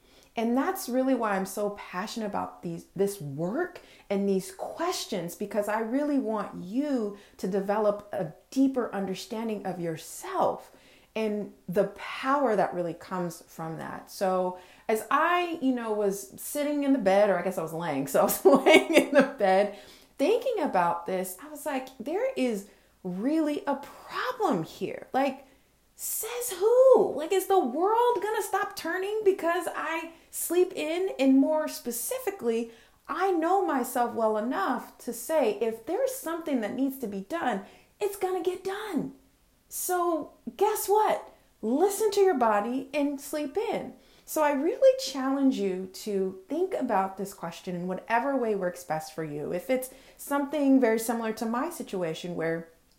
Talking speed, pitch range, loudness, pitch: 160 wpm, 200-330 Hz, -28 LUFS, 255 Hz